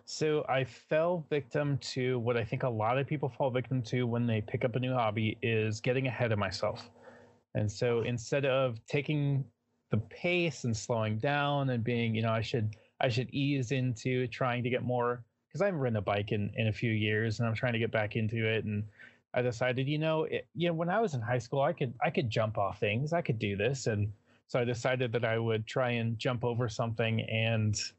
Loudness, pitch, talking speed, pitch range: -32 LUFS, 125 Hz, 230 wpm, 115-135 Hz